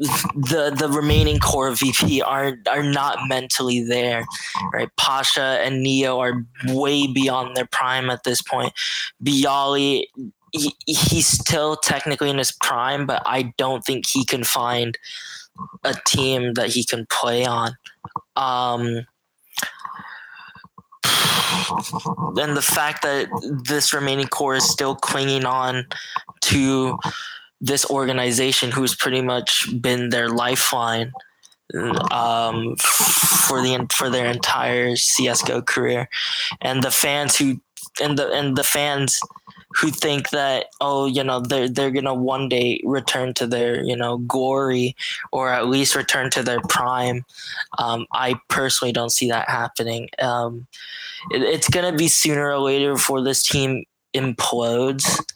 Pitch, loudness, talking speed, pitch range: 130 Hz, -20 LUFS, 135 wpm, 125-140 Hz